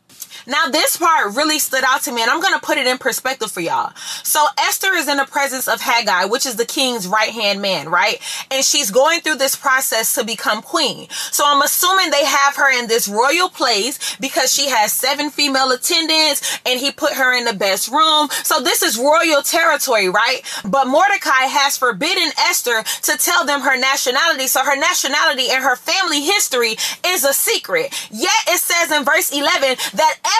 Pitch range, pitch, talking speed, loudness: 255-315 Hz, 280 Hz, 195 wpm, -15 LUFS